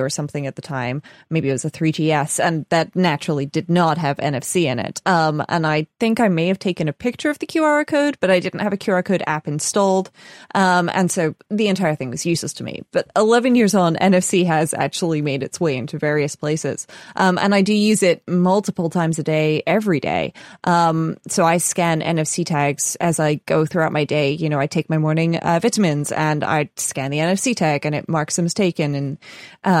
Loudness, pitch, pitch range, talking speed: -19 LUFS, 165 Hz, 150-185 Hz, 225 wpm